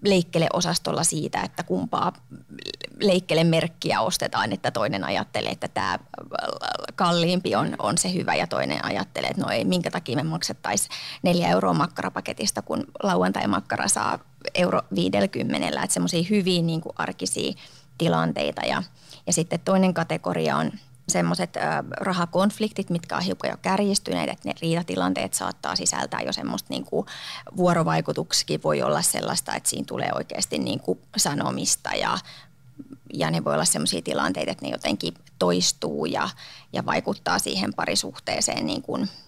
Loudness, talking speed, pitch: -25 LUFS, 140 wpm, 165 Hz